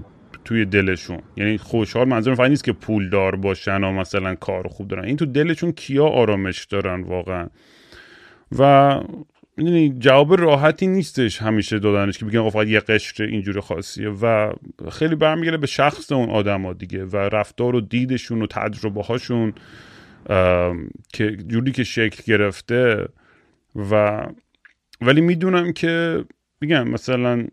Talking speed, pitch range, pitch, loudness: 140 wpm, 100-135 Hz, 110 Hz, -19 LUFS